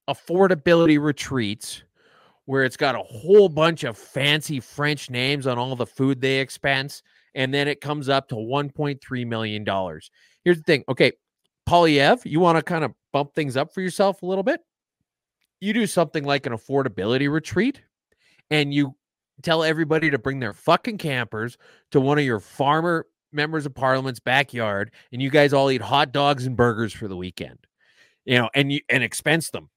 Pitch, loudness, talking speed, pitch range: 140 Hz, -22 LUFS, 180 wpm, 125-160 Hz